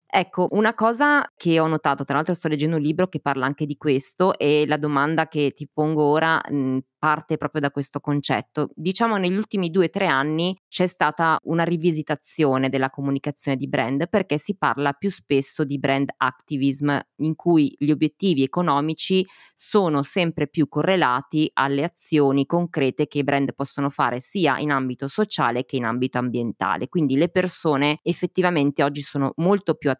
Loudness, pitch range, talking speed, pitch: -22 LUFS, 140-170 Hz, 175 wpm, 150 Hz